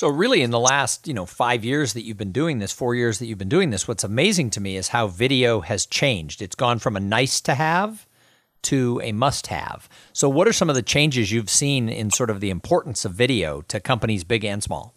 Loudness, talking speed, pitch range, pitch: -21 LUFS, 250 wpm, 110-135 Hz, 120 Hz